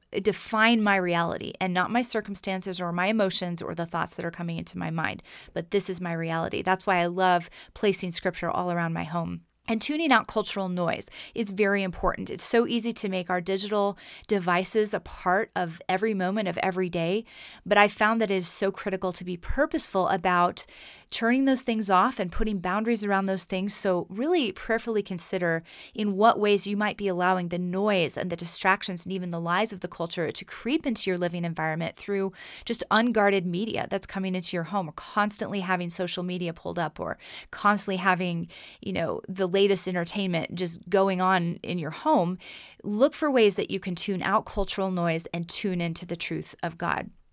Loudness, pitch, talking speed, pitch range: -26 LUFS, 190 Hz, 200 wpm, 180-210 Hz